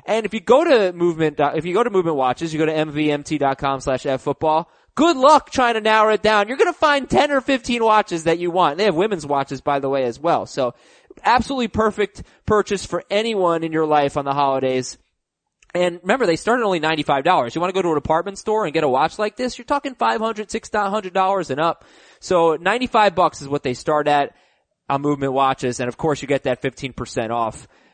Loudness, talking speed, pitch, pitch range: -19 LUFS, 235 wpm, 175 Hz, 145-215 Hz